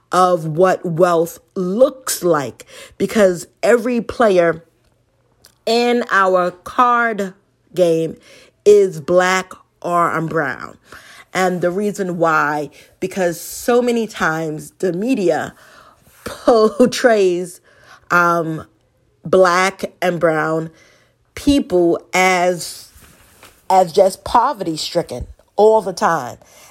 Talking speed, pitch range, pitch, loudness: 90 wpm, 160-200 Hz, 180 Hz, -16 LUFS